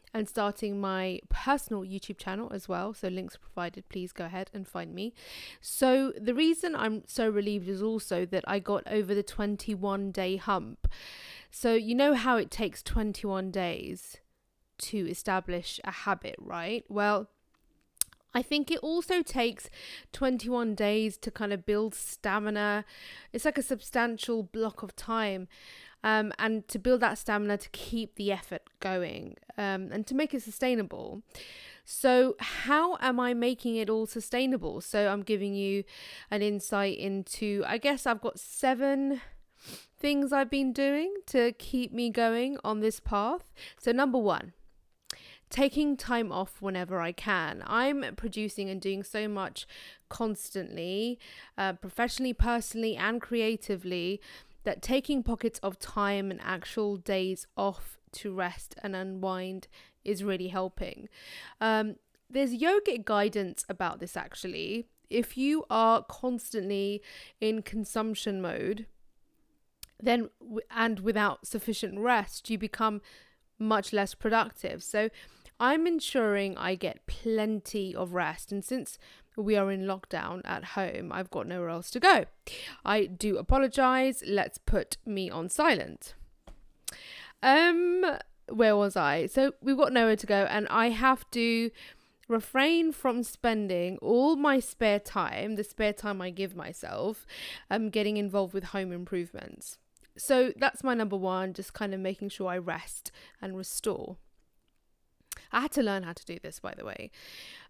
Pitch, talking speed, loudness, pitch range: 215 Hz, 145 wpm, -30 LUFS, 195-245 Hz